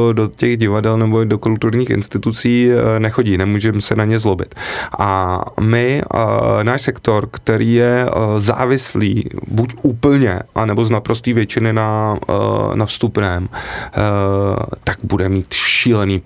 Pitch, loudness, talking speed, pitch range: 110 Hz, -16 LUFS, 120 wpm, 105-120 Hz